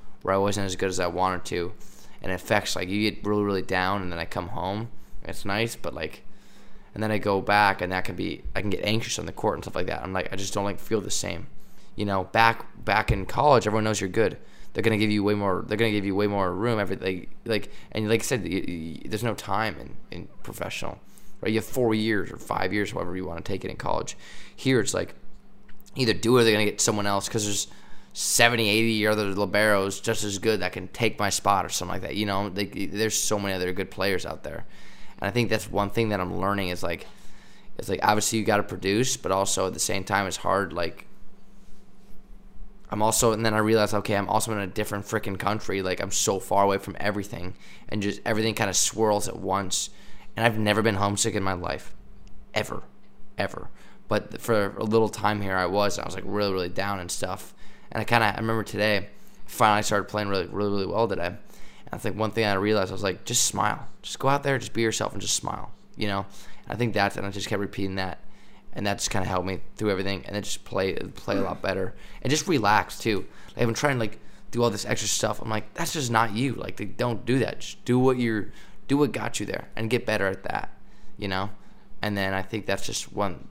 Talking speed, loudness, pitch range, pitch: 250 wpm, -26 LUFS, 95-110 Hz, 105 Hz